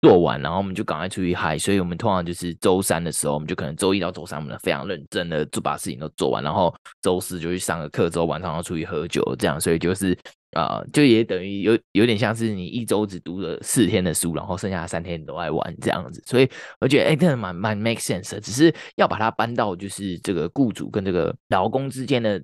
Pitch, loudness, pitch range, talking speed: 95 Hz, -23 LUFS, 85-110 Hz, 395 characters per minute